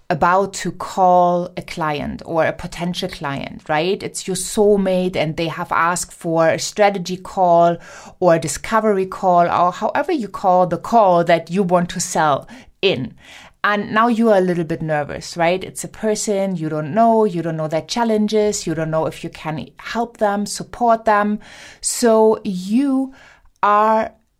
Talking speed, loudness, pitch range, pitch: 170 wpm, -18 LUFS, 170-210 Hz, 185 Hz